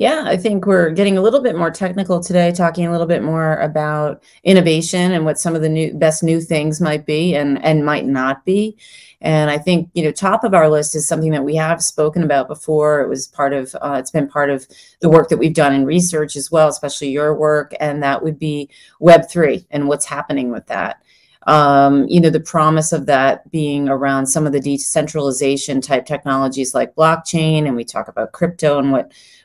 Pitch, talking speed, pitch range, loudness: 155 Hz, 215 wpm, 145-165 Hz, -16 LUFS